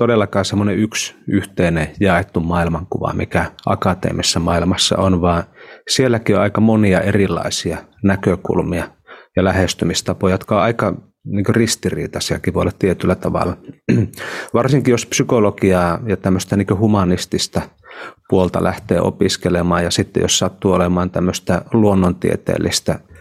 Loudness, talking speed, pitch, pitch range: -17 LUFS, 115 wpm, 95 Hz, 90-105 Hz